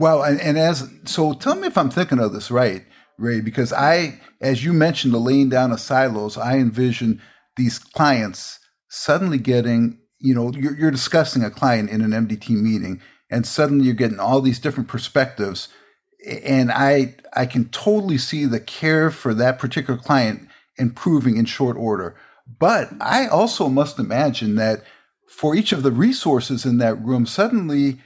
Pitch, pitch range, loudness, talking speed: 130 Hz, 115-150 Hz, -19 LUFS, 165 wpm